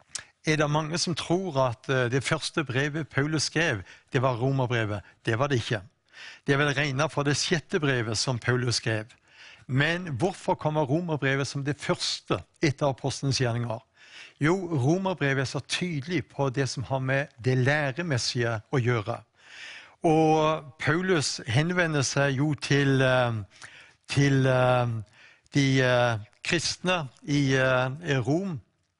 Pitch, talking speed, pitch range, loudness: 140 Hz, 130 wpm, 125-155 Hz, -26 LUFS